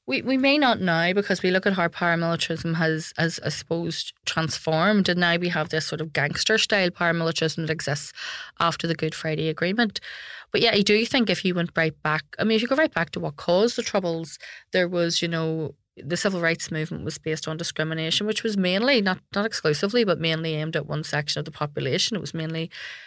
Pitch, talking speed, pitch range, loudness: 165 Hz, 220 wpm, 160-195 Hz, -24 LUFS